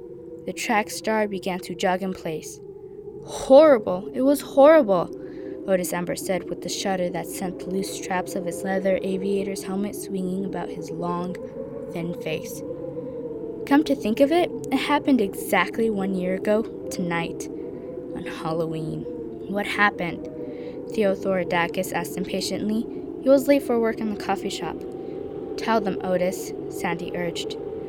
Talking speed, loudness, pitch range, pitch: 145 wpm, -24 LUFS, 185-290 Hz, 205 Hz